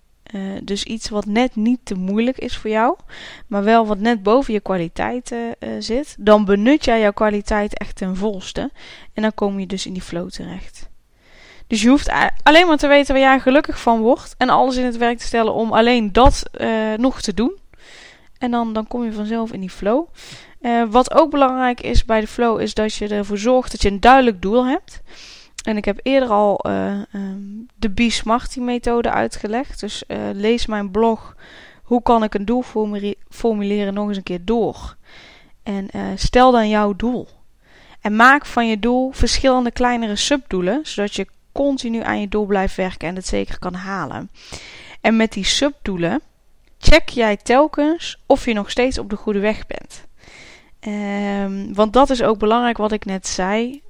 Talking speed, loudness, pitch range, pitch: 190 wpm, -18 LUFS, 205-250 Hz, 225 Hz